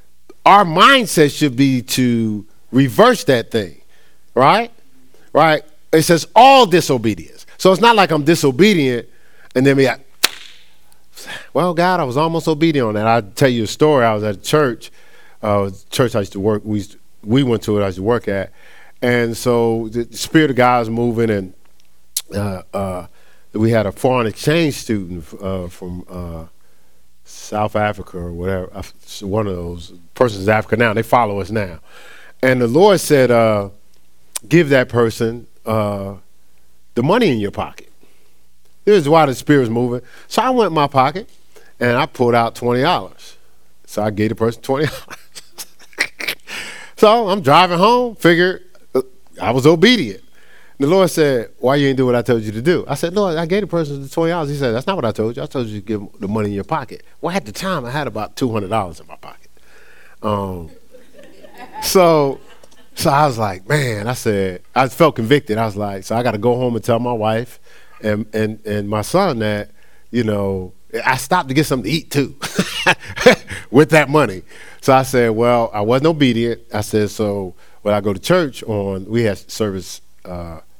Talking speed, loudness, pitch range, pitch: 195 wpm, -16 LUFS, 100-140 Hz, 115 Hz